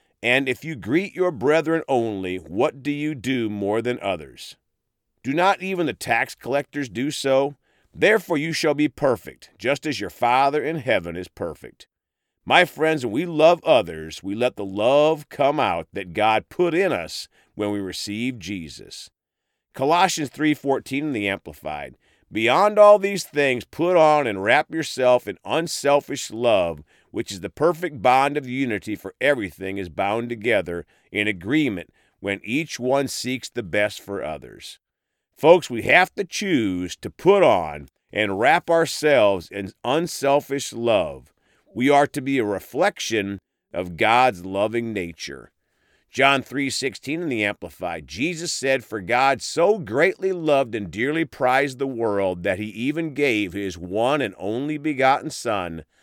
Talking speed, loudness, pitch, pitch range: 155 wpm, -22 LUFS, 135 Hz, 105-150 Hz